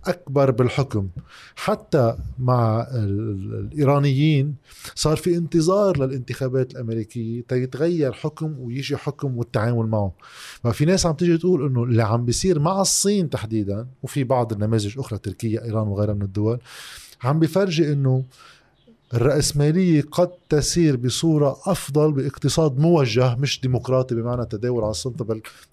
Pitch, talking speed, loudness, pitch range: 130 Hz, 130 wpm, -21 LUFS, 115-155 Hz